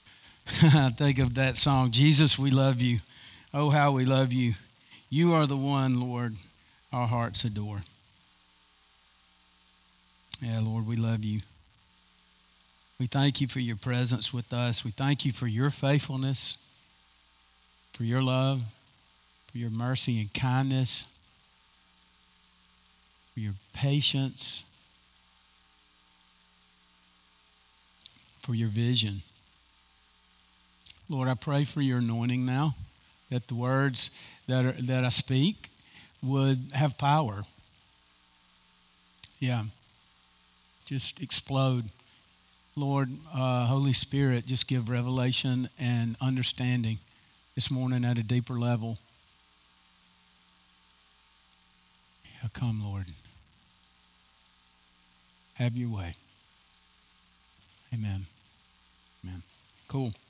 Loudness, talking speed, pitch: -28 LUFS, 100 wpm, 110 Hz